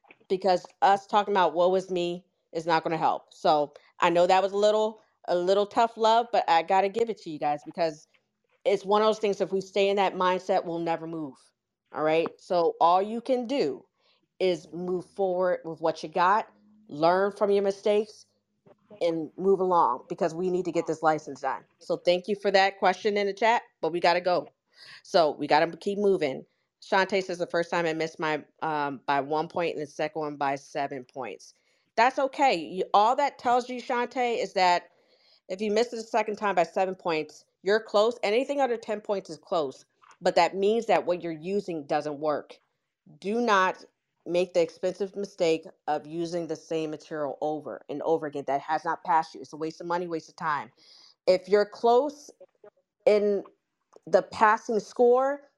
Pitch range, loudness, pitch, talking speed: 160-210 Hz, -27 LUFS, 180 Hz, 200 wpm